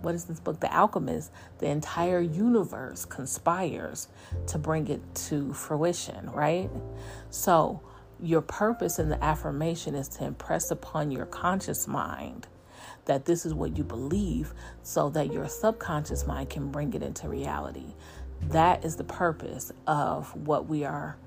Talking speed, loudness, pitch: 150 wpm, -30 LUFS, 145 Hz